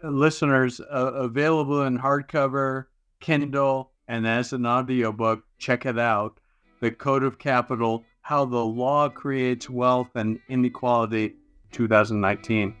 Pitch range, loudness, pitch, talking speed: 115-135 Hz, -24 LUFS, 125 Hz, 115 wpm